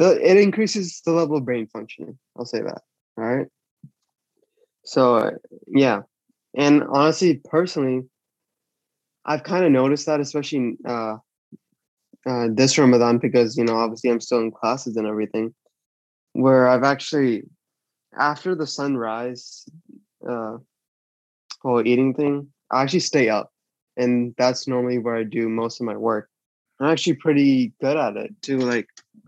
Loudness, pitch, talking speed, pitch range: -21 LUFS, 130 Hz, 145 wpm, 120-150 Hz